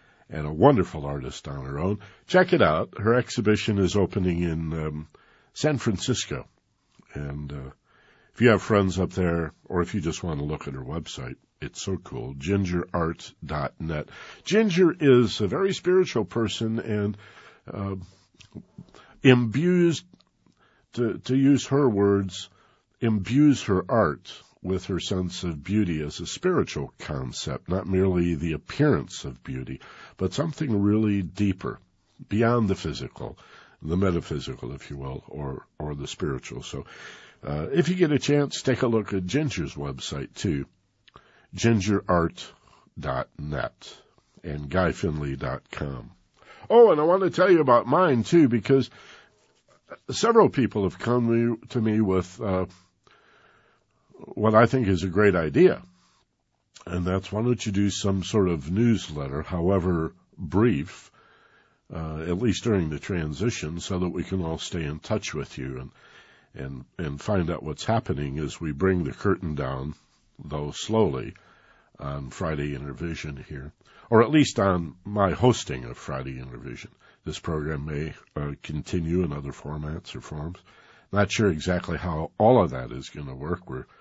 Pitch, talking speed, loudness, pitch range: 95 Hz, 150 wpm, -25 LUFS, 75-110 Hz